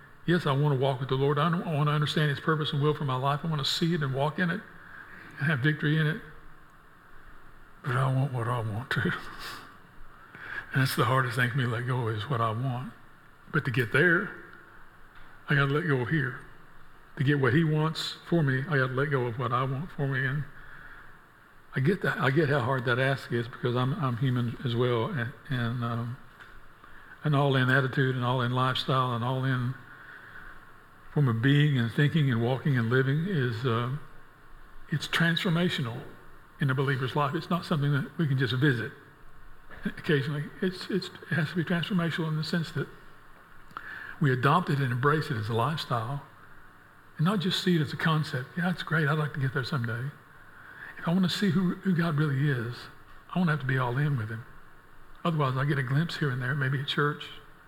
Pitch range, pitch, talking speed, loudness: 130-155 Hz, 145 Hz, 215 wpm, -28 LUFS